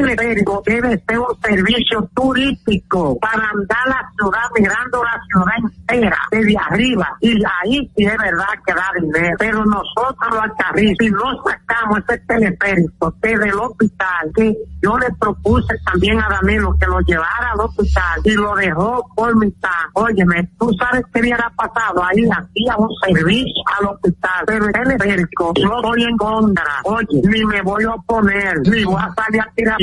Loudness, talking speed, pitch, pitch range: -16 LUFS, 175 wpm, 215 Hz, 195-230 Hz